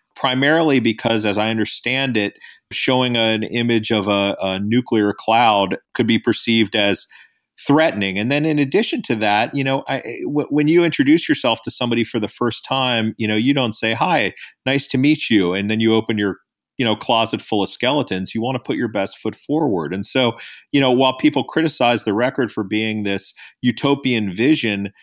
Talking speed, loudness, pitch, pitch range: 195 wpm, -18 LUFS, 115 Hz, 110-135 Hz